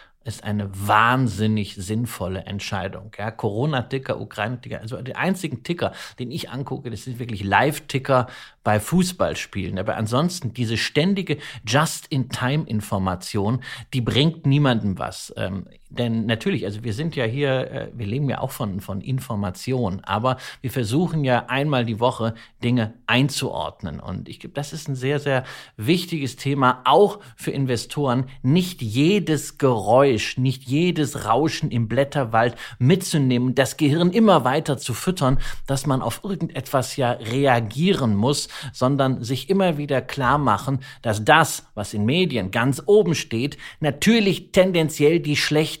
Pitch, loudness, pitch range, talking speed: 130 Hz, -22 LUFS, 115-150 Hz, 140 wpm